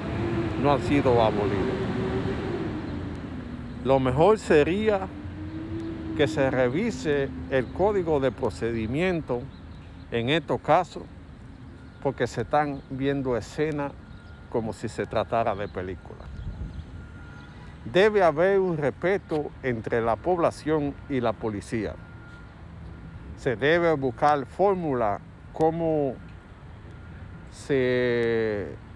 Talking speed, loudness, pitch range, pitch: 90 wpm, -26 LUFS, 95-145 Hz, 120 Hz